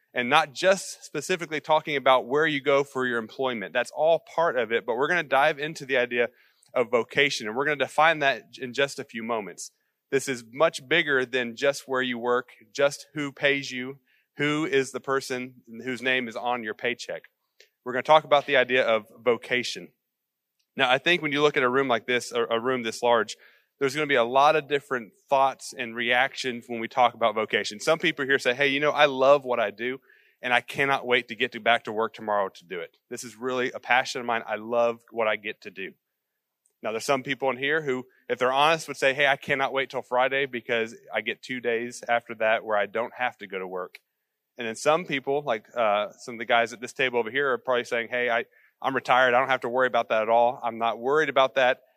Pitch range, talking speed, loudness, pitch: 120-140 Hz, 240 wpm, -25 LUFS, 130 Hz